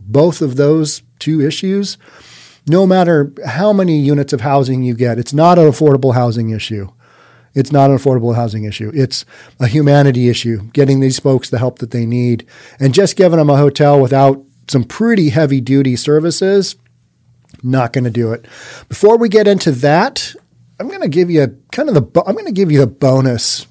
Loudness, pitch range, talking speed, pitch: -12 LUFS, 125-155 Hz, 190 wpm, 140 Hz